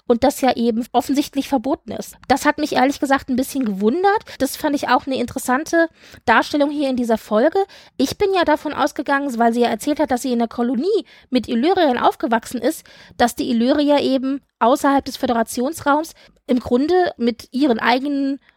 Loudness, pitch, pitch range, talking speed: -19 LUFS, 270 Hz, 245-300 Hz, 185 wpm